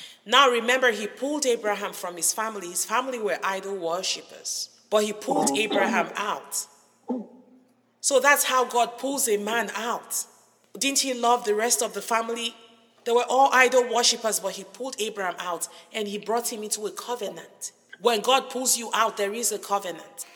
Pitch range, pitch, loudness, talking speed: 205-250 Hz, 230 Hz, -24 LUFS, 175 wpm